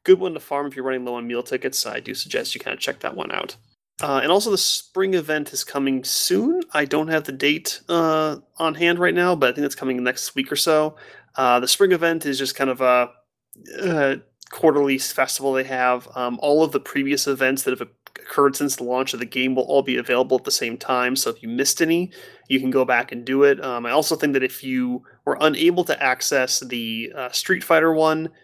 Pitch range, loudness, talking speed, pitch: 130-160 Hz, -21 LUFS, 240 wpm, 140 Hz